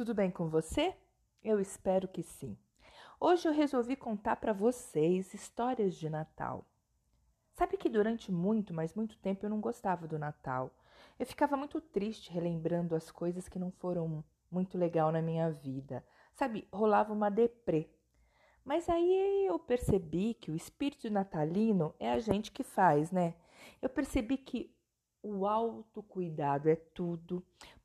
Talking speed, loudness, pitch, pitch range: 150 wpm, -34 LUFS, 195 Hz, 165-235 Hz